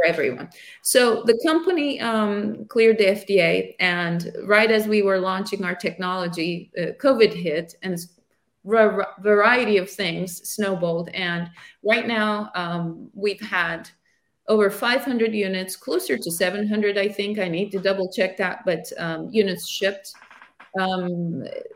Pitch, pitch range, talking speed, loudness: 200 Hz, 180-215 Hz, 140 wpm, -22 LUFS